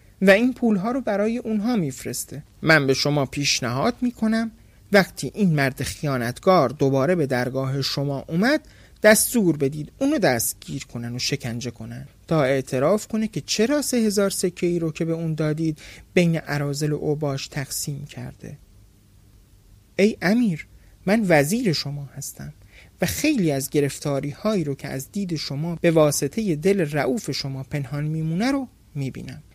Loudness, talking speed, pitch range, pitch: -22 LUFS, 145 wpm, 135-195 Hz, 150 Hz